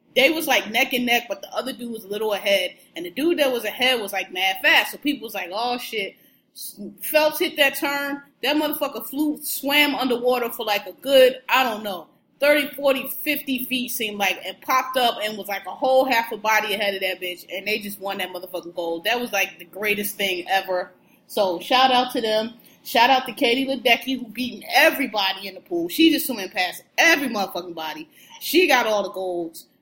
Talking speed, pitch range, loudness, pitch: 220 wpm, 195-275 Hz, -21 LUFS, 240 Hz